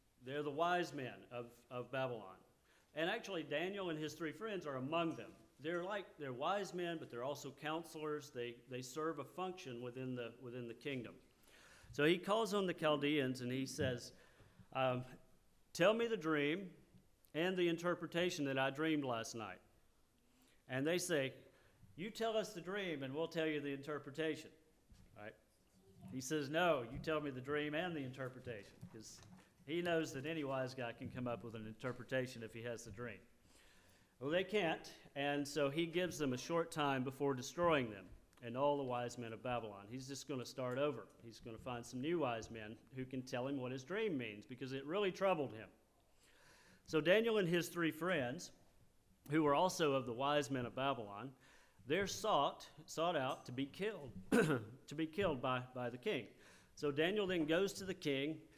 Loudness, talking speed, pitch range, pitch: -41 LUFS, 190 wpm, 125-165 Hz, 140 Hz